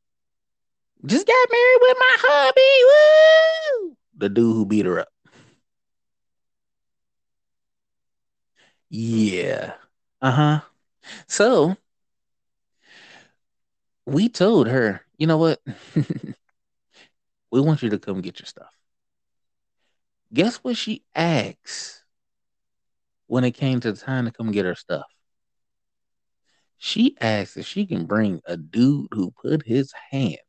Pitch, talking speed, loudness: 150 Hz, 110 wpm, -19 LUFS